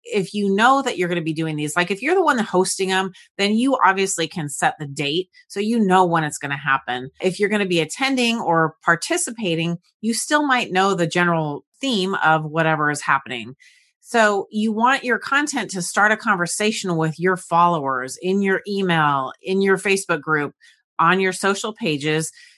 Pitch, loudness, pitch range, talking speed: 185 Hz, -20 LUFS, 160-220 Hz, 195 wpm